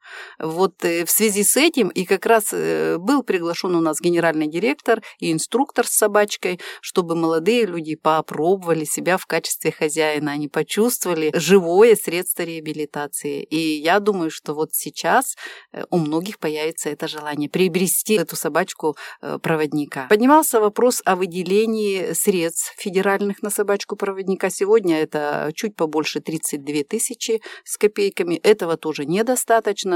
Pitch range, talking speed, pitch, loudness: 155-215 Hz, 130 wpm, 180 Hz, -20 LUFS